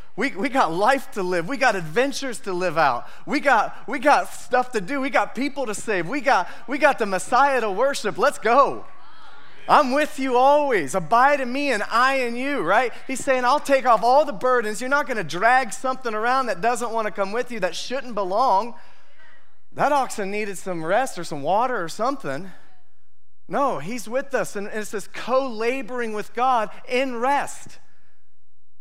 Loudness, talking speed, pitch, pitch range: -22 LUFS, 195 wpm, 250 Hz, 210-270 Hz